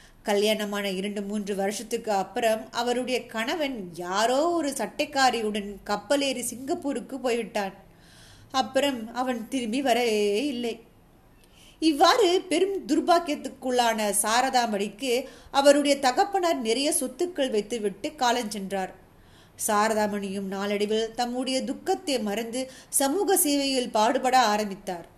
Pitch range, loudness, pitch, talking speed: 210-275 Hz, -26 LUFS, 240 Hz, 90 wpm